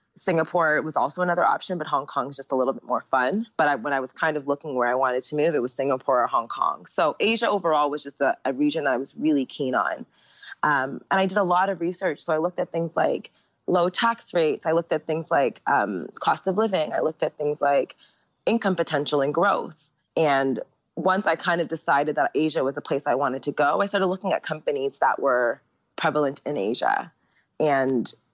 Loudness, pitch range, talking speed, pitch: -24 LUFS, 140-185 Hz, 230 wpm, 155 Hz